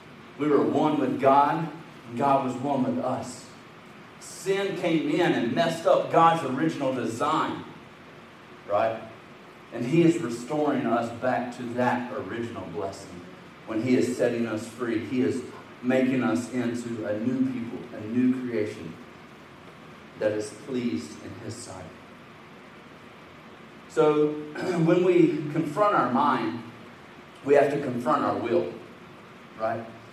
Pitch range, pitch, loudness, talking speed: 115-155 Hz, 125 Hz, -26 LUFS, 135 wpm